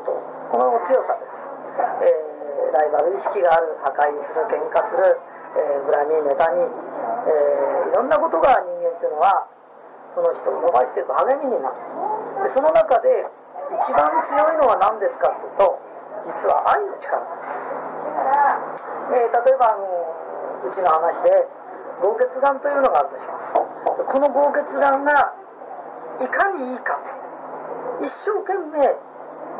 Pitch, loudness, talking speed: 325 Hz, -20 LUFS, 255 characters per minute